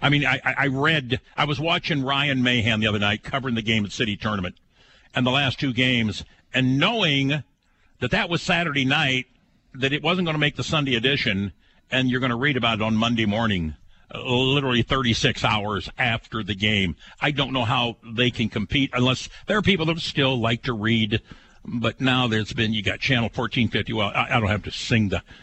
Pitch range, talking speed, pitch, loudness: 110-140 Hz, 210 wpm, 125 Hz, -22 LUFS